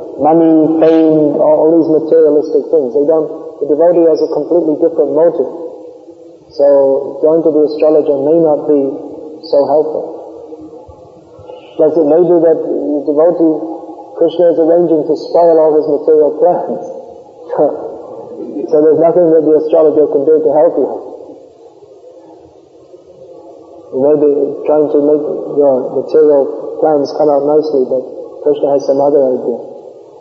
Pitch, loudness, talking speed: 165 Hz, -11 LUFS, 140 wpm